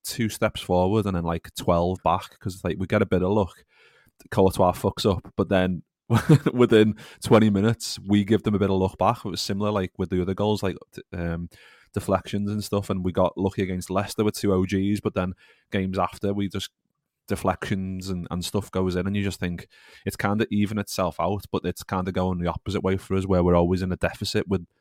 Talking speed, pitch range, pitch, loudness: 225 wpm, 90-105 Hz, 95 Hz, -25 LUFS